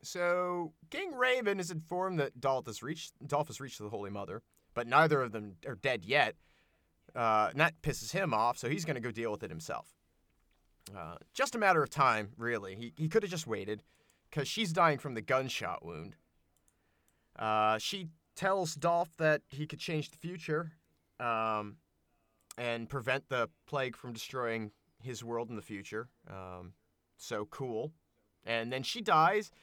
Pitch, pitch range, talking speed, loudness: 120 Hz, 105-155 Hz, 175 wpm, -34 LUFS